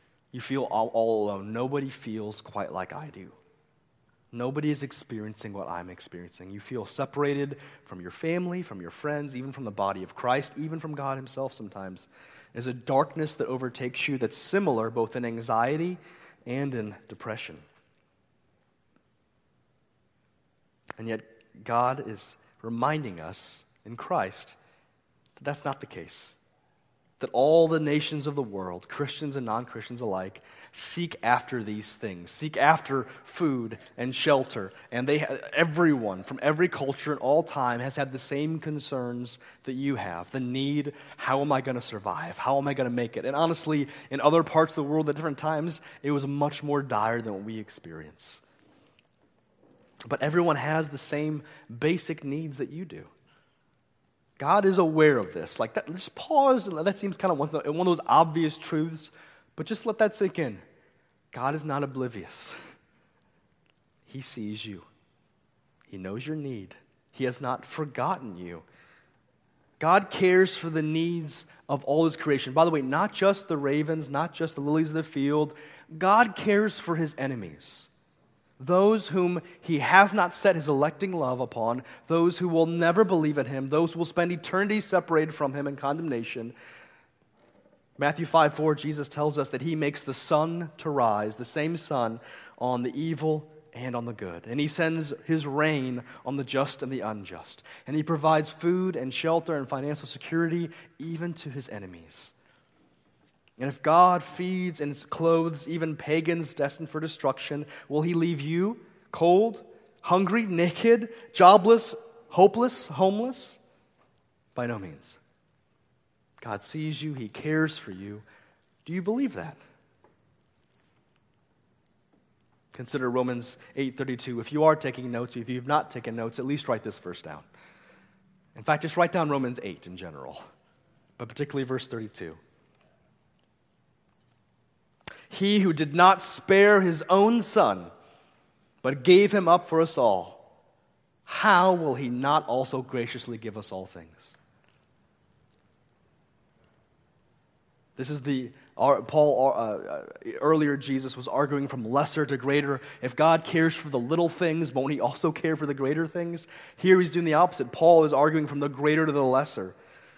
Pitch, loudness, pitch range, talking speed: 145 Hz, -27 LUFS, 125-165 Hz, 160 wpm